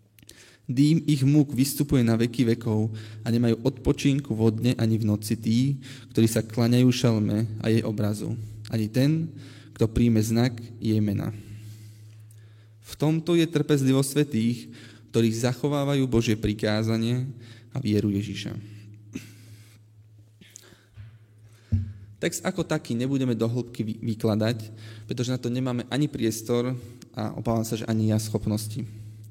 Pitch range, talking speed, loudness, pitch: 110-125 Hz, 125 wpm, -25 LUFS, 115 Hz